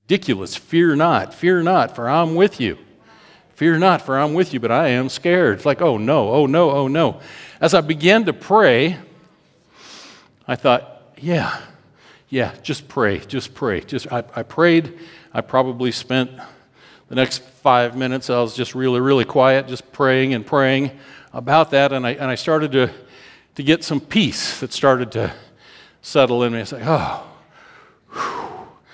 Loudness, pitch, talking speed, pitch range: -18 LUFS, 135 Hz, 175 wpm, 130-165 Hz